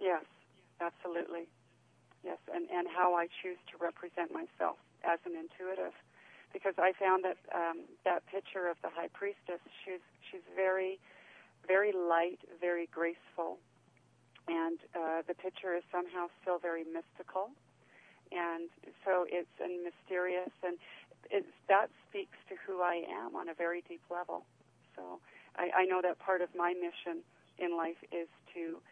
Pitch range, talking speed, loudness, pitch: 170-185 Hz, 150 wpm, -37 LUFS, 175 Hz